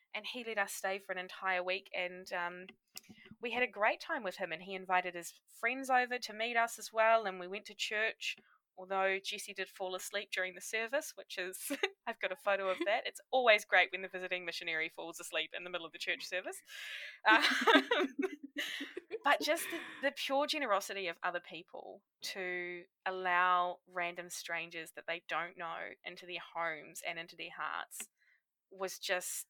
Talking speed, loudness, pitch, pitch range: 190 wpm, -36 LUFS, 190 Hz, 180-230 Hz